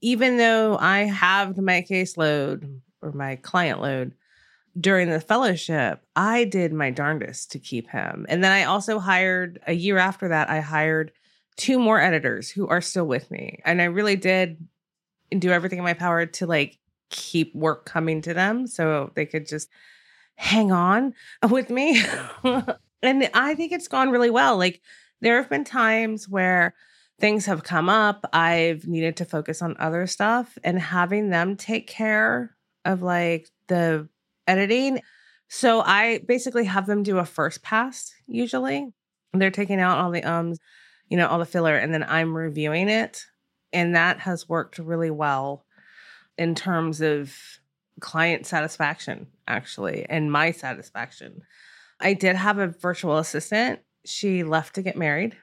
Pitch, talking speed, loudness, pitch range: 180 Hz, 160 wpm, -23 LUFS, 160-215 Hz